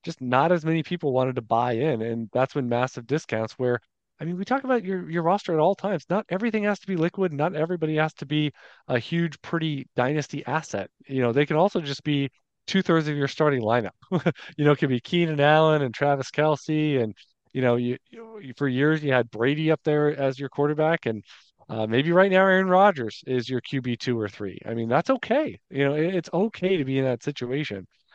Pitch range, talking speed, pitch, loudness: 125-170 Hz, 225 wpm, 150 Hz, -24 LUFS